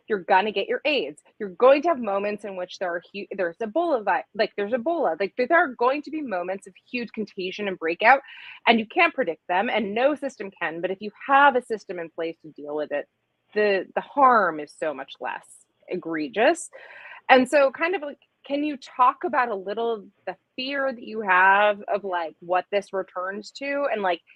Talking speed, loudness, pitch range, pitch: 215 wpm, -24 LUFS, 185-265 Hz, 210 Hz